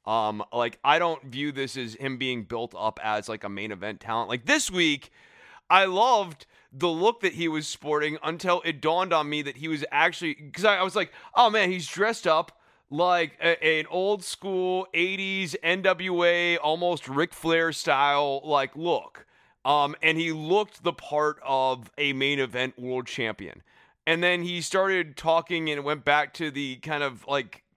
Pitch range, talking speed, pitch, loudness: 135-175 Hz, 180 wpm, 155 Hz, -25 LUFS